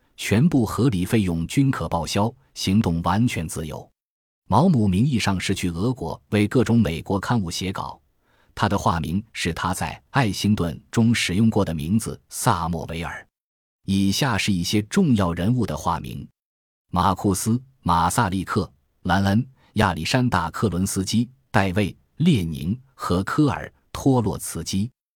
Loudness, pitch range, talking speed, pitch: -22 LUFS, 90-115 Hz, 225 characters per minute, 100 Hz